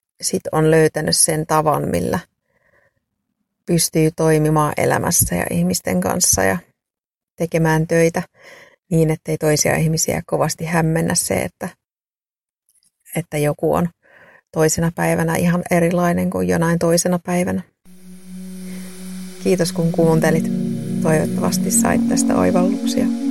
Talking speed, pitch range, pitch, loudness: 105 wpm, 155-185 Hz, 170 Hz, -18 LUFS